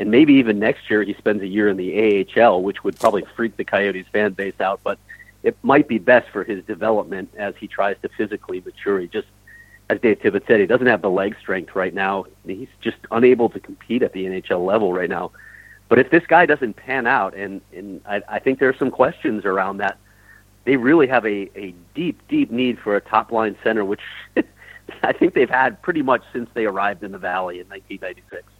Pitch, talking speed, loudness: 115 Hz, 220 wpm, -19 LUFS